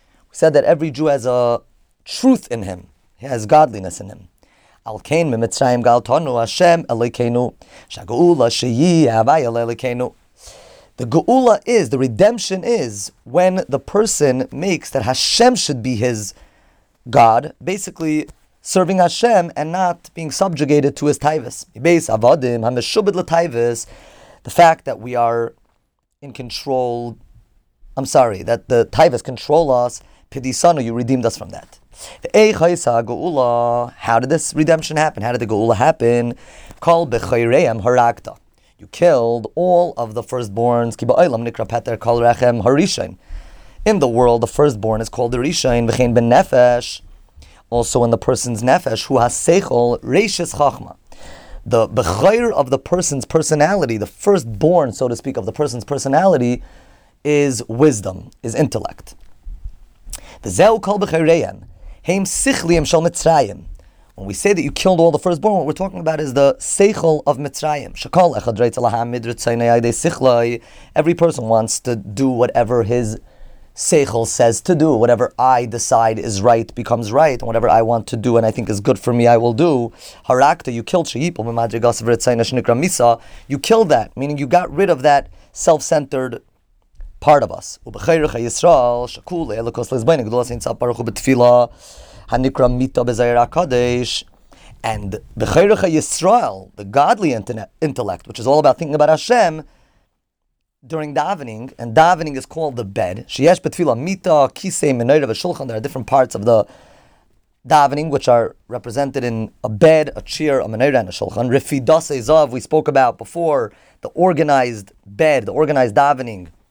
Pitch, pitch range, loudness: 125 Hz, 115-155 Hz, -16 LUFS